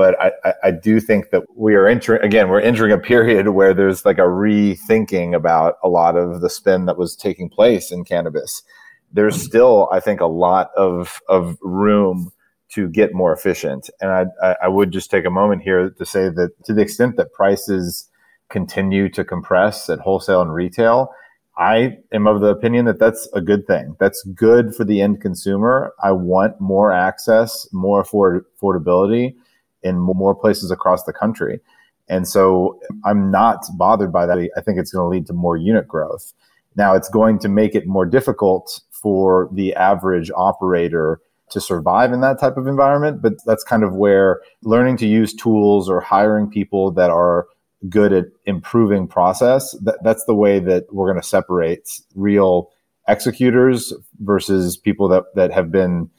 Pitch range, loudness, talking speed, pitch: 95-110 Hz, -16 LUFS, 175 wpm, 100 Hz